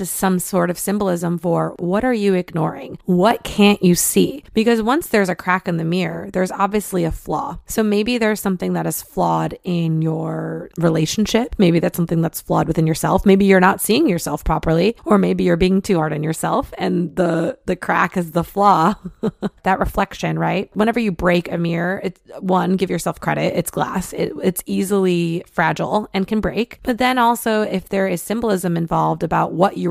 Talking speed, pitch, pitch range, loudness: 195 wpm, 185 Hz, 170-200 Hz, -18 LUFS